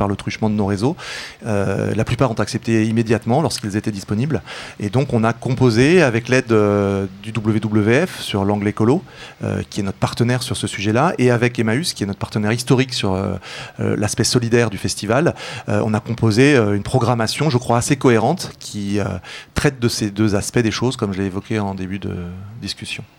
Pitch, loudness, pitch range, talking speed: 110 Hz, -19 LUFS, 105-125 Hz, 200 wpm